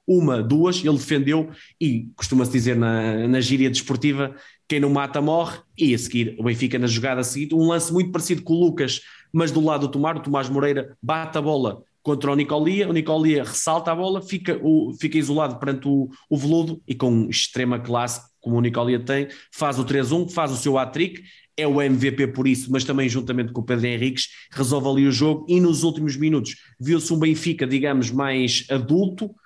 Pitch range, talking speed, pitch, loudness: 130-160 Hz, 200 wpm, 140 Hz, -22 LUFS